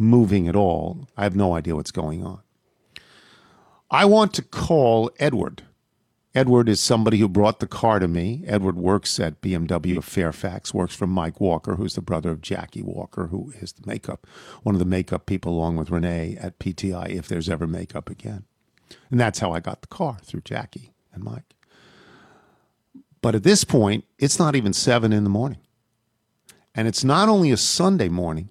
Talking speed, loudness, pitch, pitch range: 185 wpm, -22 LUFS, 100 Hz, 90-120 Hz